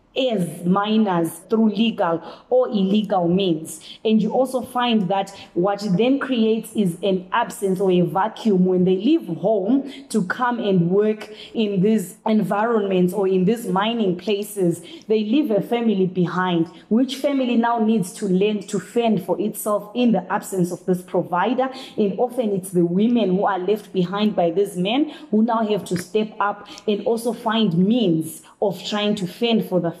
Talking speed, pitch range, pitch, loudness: 170 wpm, 185-225 Hz, 205 Hz, -21 LUFS